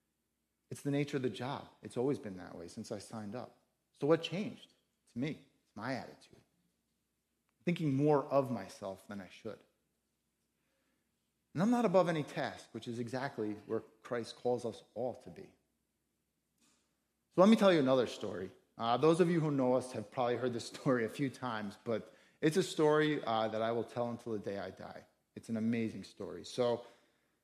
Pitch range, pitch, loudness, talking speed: 115-155 Hz, 125 Hz, -35 LUFS, 190 wpm